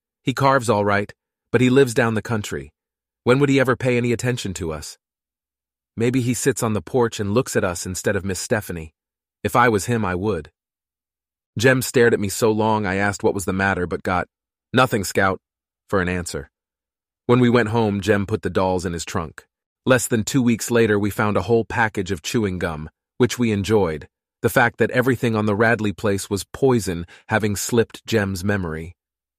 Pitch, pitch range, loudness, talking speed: 105 Hz, 95-120 Hz, -20 LUFS, 200 wpm